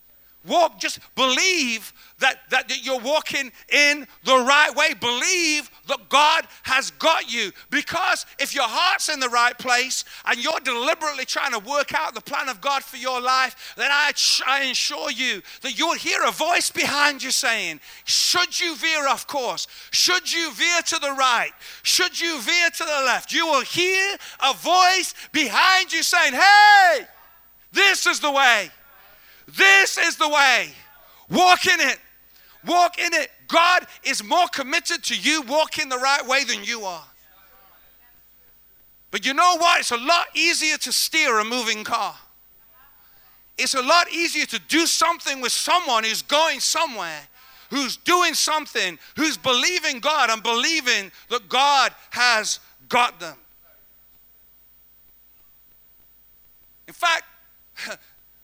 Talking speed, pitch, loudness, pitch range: 150 wpm, 295 Hz, -19 LUFS, 260-335 Hz